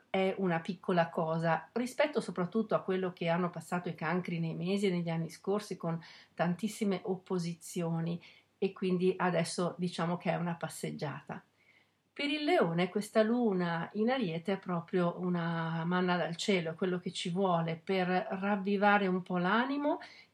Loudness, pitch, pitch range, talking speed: -33 LUFS, 180 Hz, 170-200 Hz, 155 wpm